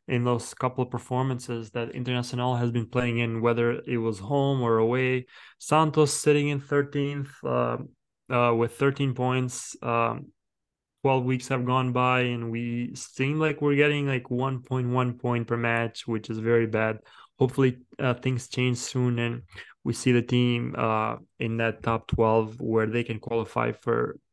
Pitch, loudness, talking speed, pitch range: 125 Hz, -26 LUFS, 165 wpm, 115-130 Hz